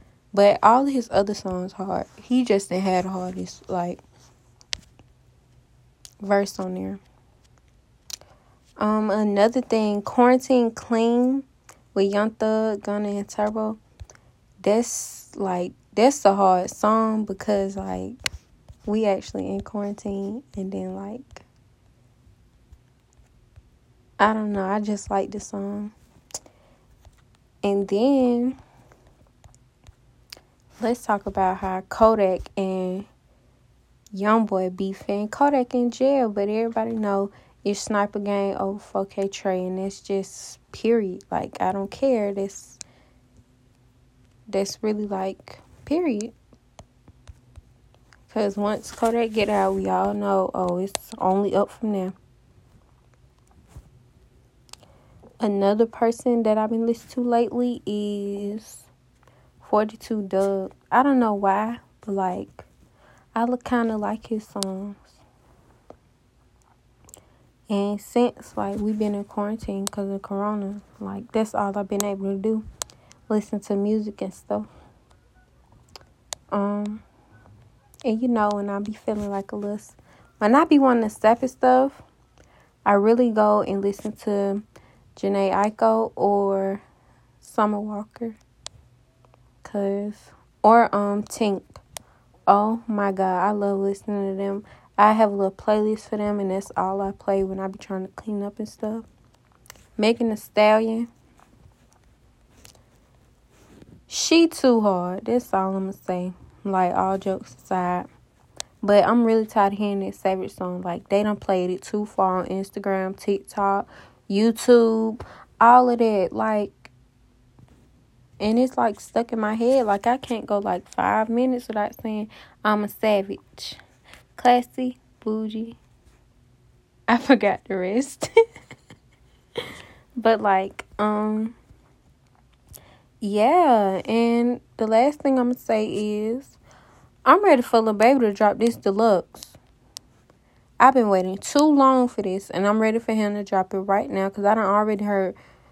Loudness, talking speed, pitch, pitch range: -23 LUFS, 130 wpm, 205 Hz, 195-225 Hz